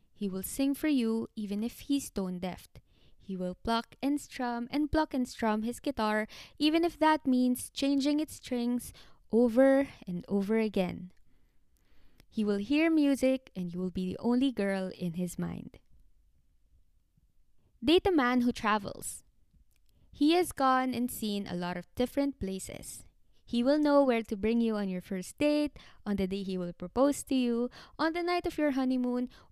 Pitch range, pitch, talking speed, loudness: 195-280 Hz, 240 Hz, 175 wpm, -31 LUFS